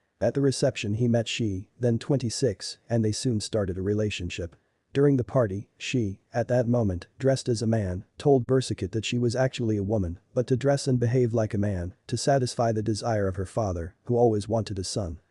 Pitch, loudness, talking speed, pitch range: 115 Hz, -27 LUFS, 210 wpm, 100-125 Hz